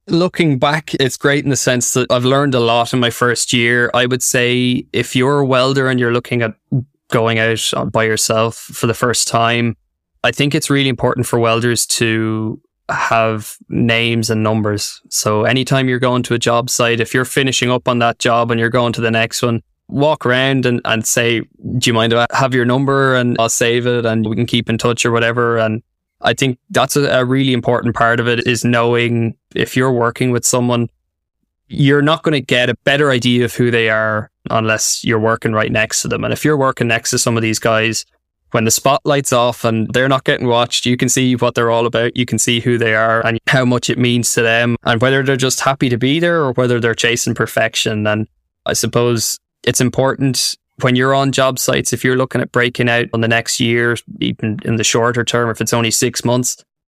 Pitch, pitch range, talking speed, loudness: 120 Hz, 115-130 Hz, 225 wpm, -15 LUFS